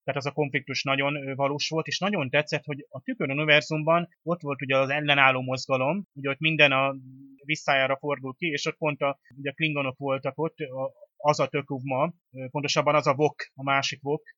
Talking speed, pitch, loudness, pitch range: 190 wpm, 145 Hz, -26 LUFS, 135-155 Hz